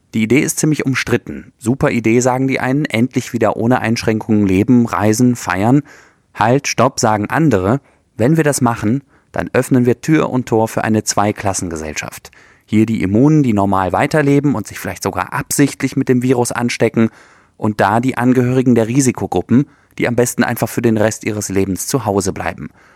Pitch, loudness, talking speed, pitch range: 120 Hz, -15 LUFS, 175 wpm, 105-130 Hz